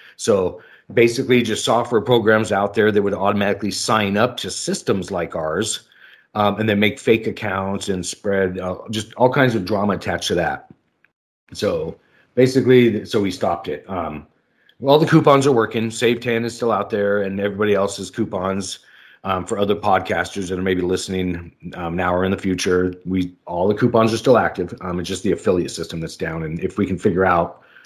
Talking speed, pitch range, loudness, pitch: 195 wpm, 95-115 Hz, -19 LUFS, 100 Hz